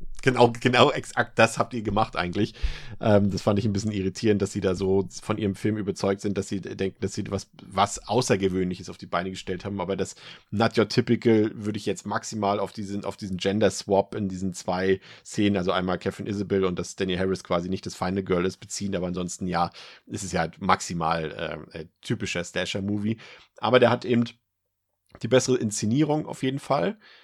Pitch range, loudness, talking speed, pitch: 95-110 Hz, -26 LUFS, 200 wpm, 100 Hz